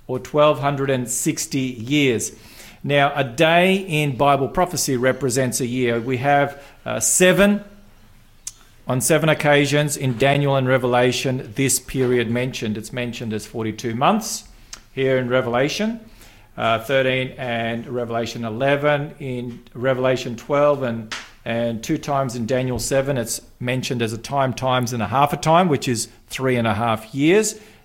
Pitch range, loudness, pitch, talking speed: 120-145 Hz, -20 LUFS, 130 Hz, 145 wpm